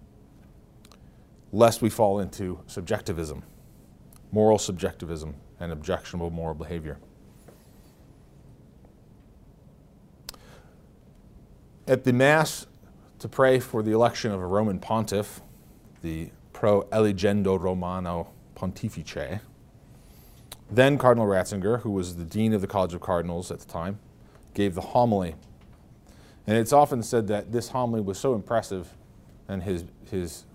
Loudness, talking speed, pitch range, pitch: -26 LUFS, 115 wpm, 85-115 Hz, 100 Hz